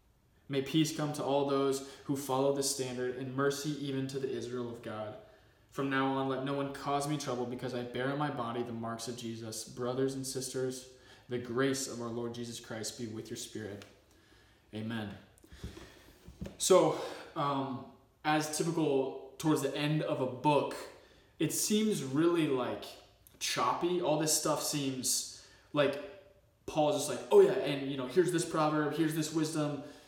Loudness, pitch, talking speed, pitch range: -33 LUFS, 135 Hz, 170 wpm, 125-150 Hz